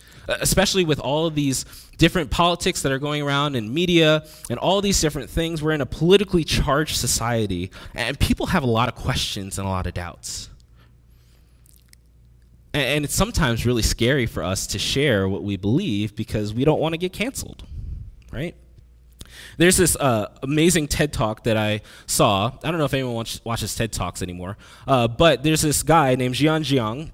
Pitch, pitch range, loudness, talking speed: 125 Hz, 100-155 Hz, -21 LUFS, 185 wpm